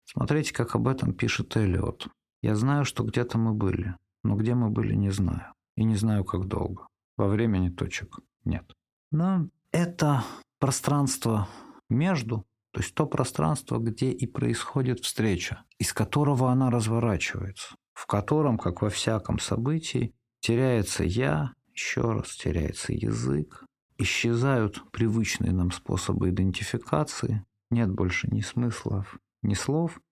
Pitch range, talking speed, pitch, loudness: 100-130 Hz, 130 wpm, 115 Hz, -28 LUFS